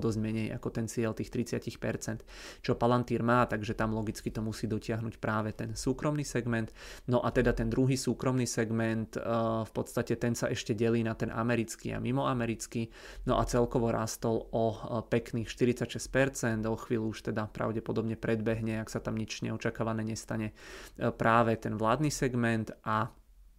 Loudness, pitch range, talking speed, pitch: -32 LUFS, 110-120 Hz, 160 wpm, 115 Hz